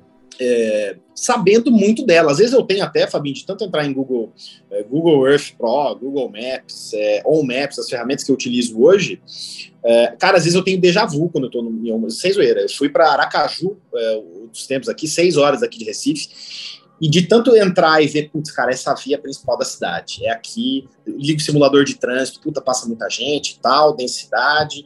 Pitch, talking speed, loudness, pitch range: 150 Hz, 205 wpm, -17 LUFS, 135-200 Hz